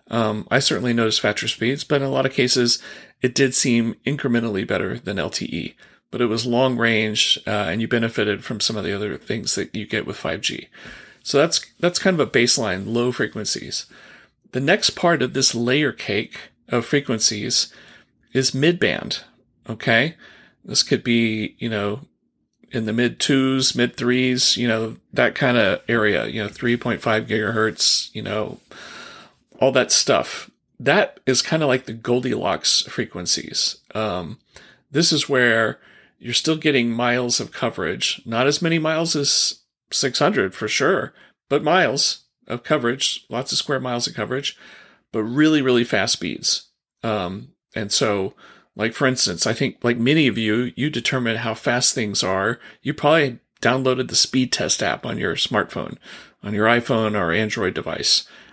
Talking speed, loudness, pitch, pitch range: 170 wpm, -20 LUFS, 120 Hz, 115-135 Hz